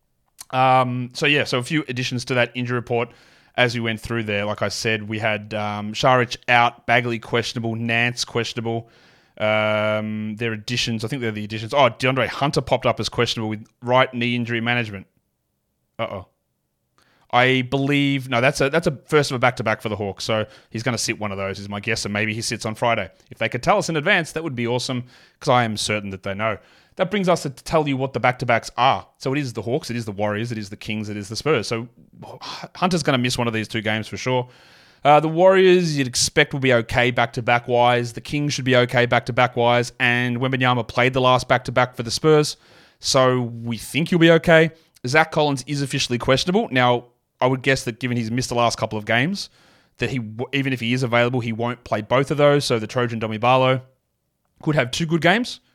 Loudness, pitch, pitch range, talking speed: -20 LUFS, 120 Hz, 115-135 Hz, 235 wpm